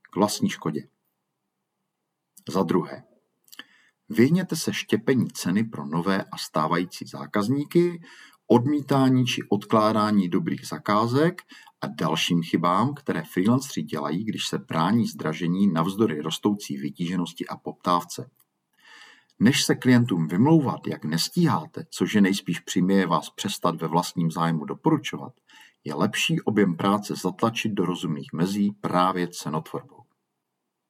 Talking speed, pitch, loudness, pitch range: 115 wpm, 100 Hz, -24 LUFS, 85-120 Hz